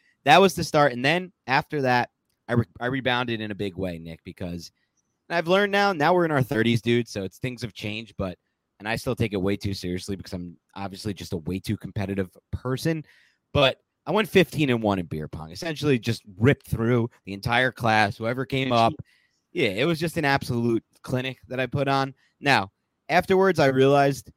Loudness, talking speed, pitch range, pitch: -24 LUFS, 205 wpm, 100-140 Hz, 120 Hz